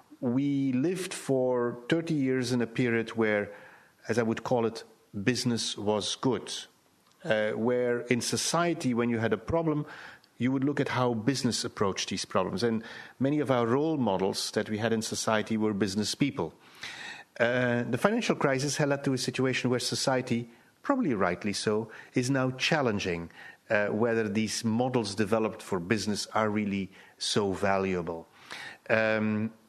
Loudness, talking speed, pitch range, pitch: -29 LUFS, 160 wpm, 110-130 Hz, 120 Hz